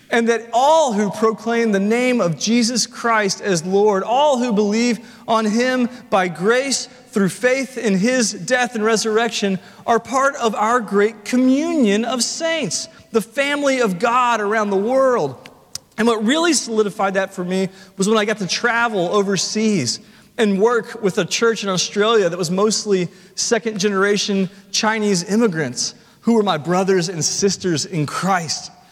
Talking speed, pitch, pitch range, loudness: 160 wpm, 215 Hz, 195-235 Hz, -18 LUFS